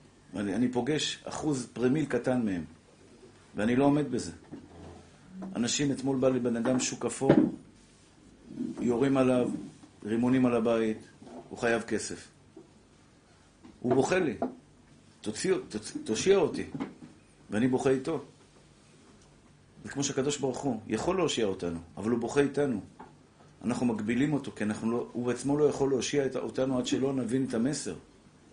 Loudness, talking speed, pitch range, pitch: -30 LUFS, 135 wpm, 115-140 Hz, 130 Hz